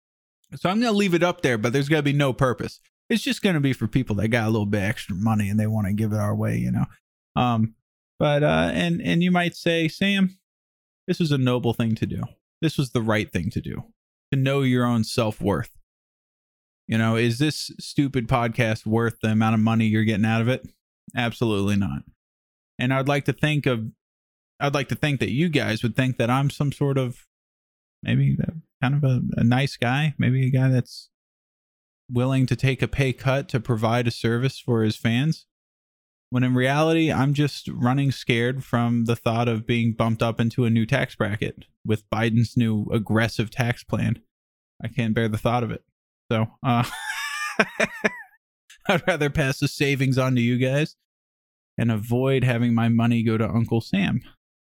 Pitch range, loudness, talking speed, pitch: 110-140 Hz, -23 LUFS, 200 wpm, 120 Hz